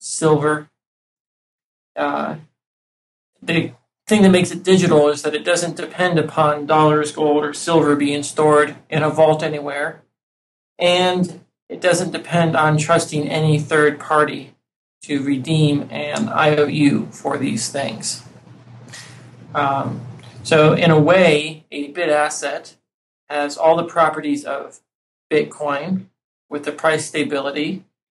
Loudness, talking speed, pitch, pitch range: -18 LUFS, 125 wpm, 150 Hz, 145-160 Hz